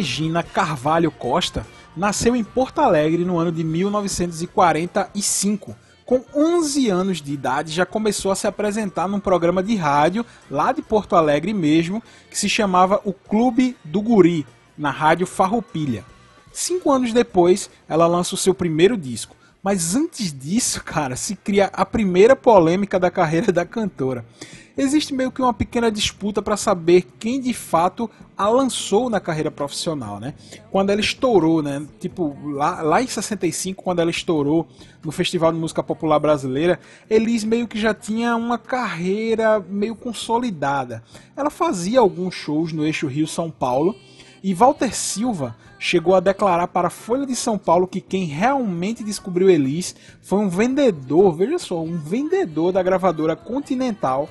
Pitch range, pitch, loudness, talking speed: 160-220 Hz, 190 Hz, -20 LUFS, 155 wpm